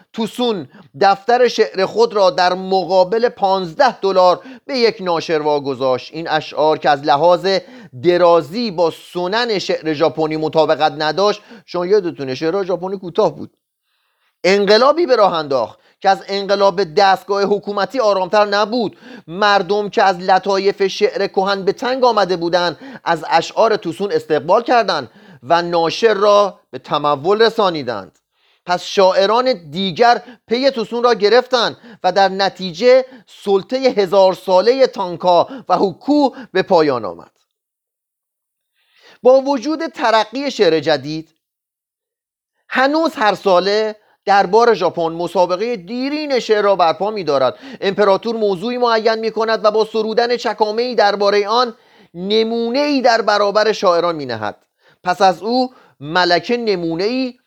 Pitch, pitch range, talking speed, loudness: 200 Hz, 180-230 Hz, 130 wpm, -16 LUFS